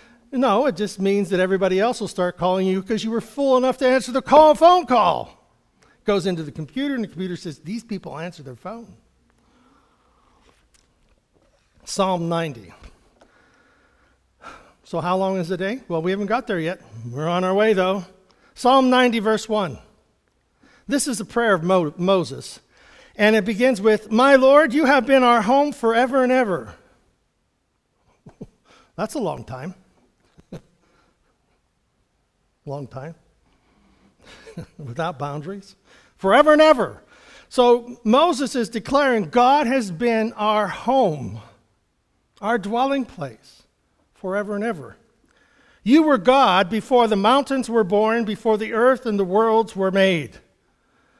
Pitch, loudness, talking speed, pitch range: 215 Hz, -19 LUFS, 145 wpm, 185-255 Hz